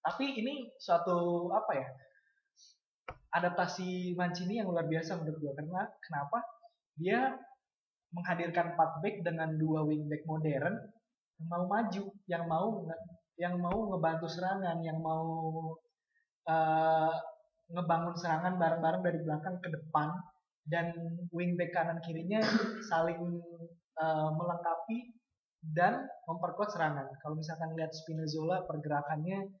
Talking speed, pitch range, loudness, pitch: 120 wpm, 160-190 Hz, -35 LUFS, 170 Hz